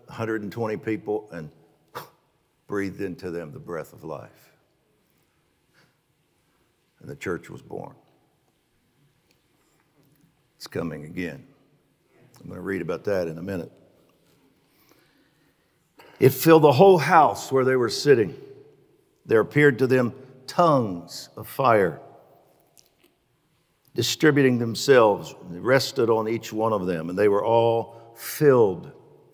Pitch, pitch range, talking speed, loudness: 115 Hz, 105-135 Hz, 120 wpm, -22 LUFS